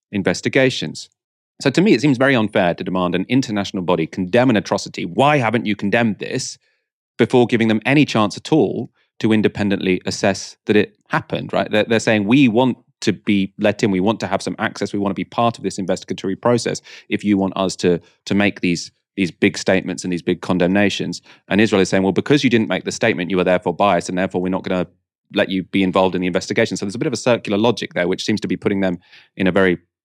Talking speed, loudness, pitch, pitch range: 240 wpm, -18 LUFS, 100 Hz, 95-115 Hz